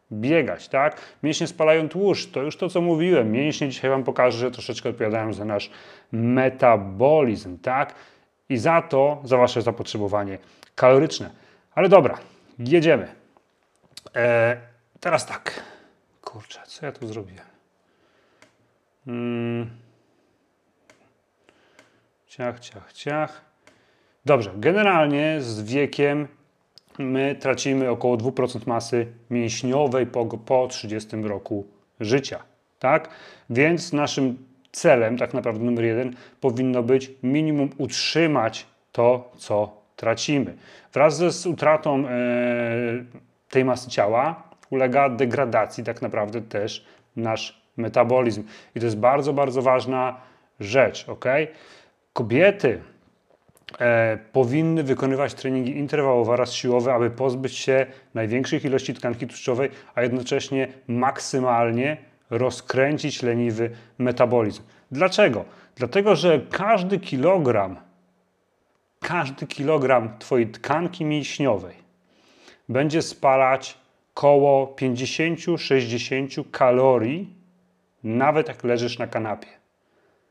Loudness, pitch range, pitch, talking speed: -22 LUFS, 120-145 Hz, 130 Hz, 100 wpm